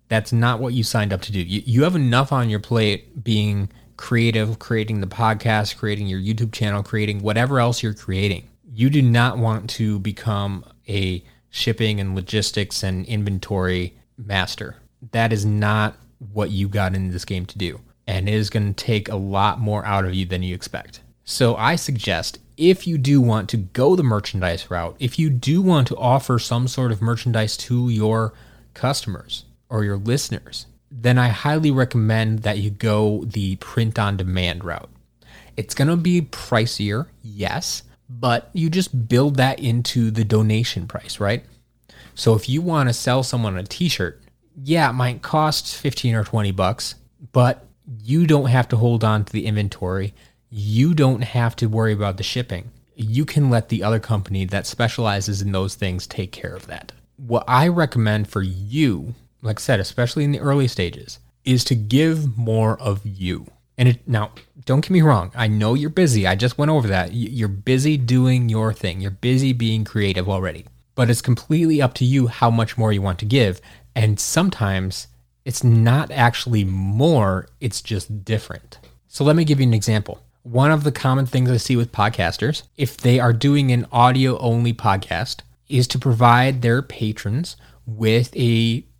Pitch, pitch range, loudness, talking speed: 115 Hz, 105-125 Hz, -20 LUFS, 185 wpm